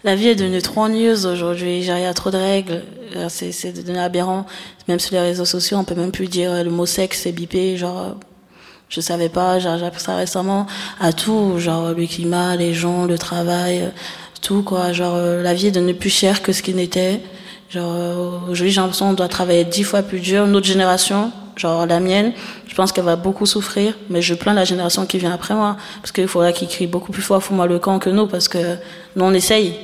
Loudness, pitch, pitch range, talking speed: -18 LUFS, 185 Hz, 175-195 Hz, 225 wpm